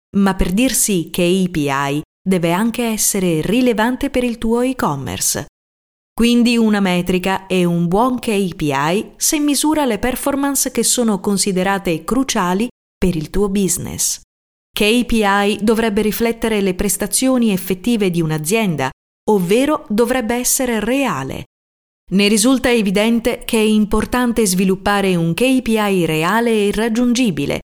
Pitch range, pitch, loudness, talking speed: 185-240 Hz, 210 Hz, -16 LUFS, 120 wpm